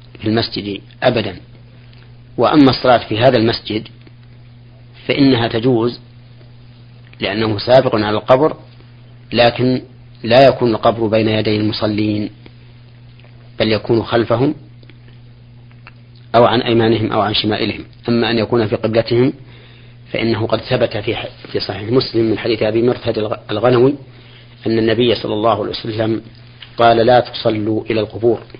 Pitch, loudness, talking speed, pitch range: 120 Hz, -15 LUFS, 120 wpm, 110-120 Hz